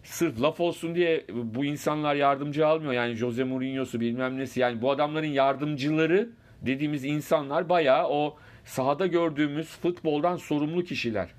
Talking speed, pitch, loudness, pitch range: 135 wpm, 145 Hz, -27 LUFS, 130-160 Hz